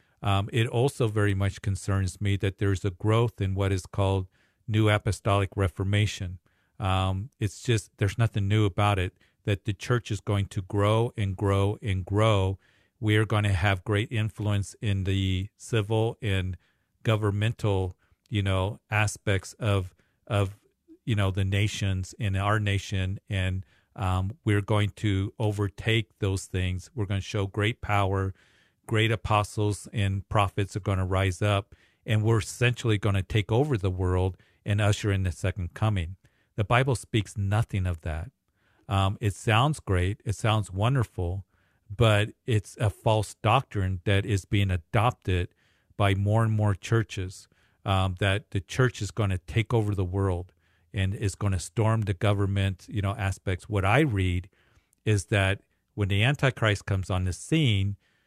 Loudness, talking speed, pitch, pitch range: -27 LUFS, 165 wpm, 100 Hz, 95-110 Hz